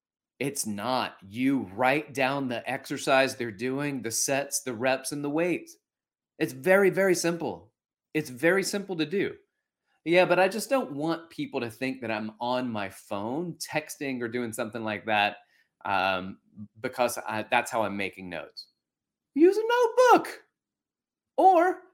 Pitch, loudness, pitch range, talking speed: 140 Hz, -27 LUFS, 120-185 Hz, 155 wpm